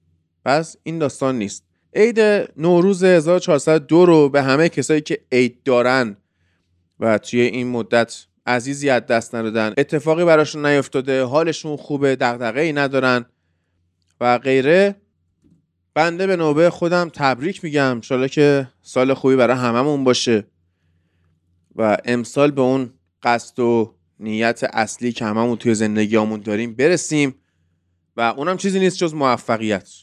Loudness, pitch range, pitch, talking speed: -18 LUFS, 110-145 Hz, 125 Hz, 130 wpm